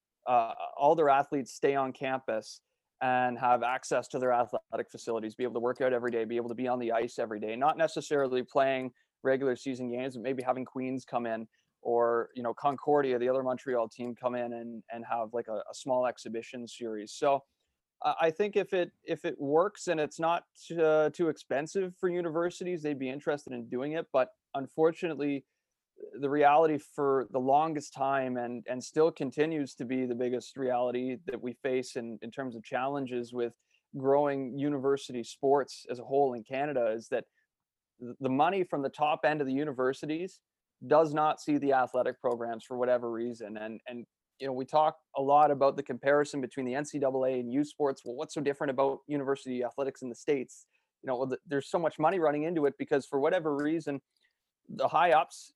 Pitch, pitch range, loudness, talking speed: 135 Hz, 125-145 Hz, -31 LUFS, 200 wpm